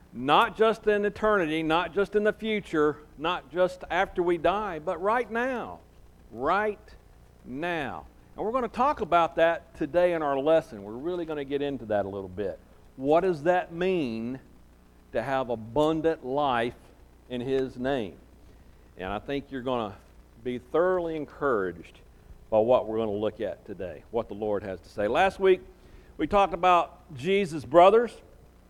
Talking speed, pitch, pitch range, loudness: 170 wpm, 155 Hz, 120-185 Hz, -27 LUFS